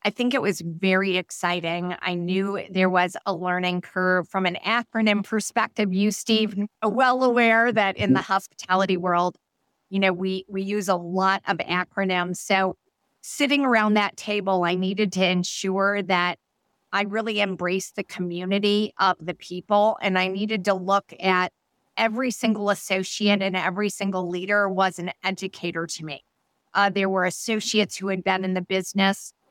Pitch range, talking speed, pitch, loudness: 180-205 Hz, 165 wpm, 190 Hz, -23 LUFS